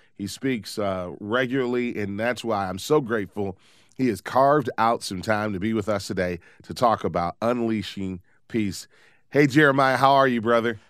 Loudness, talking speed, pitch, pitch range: -23 LUFS, 175 wpm, 110 Hz, 100-125 Hz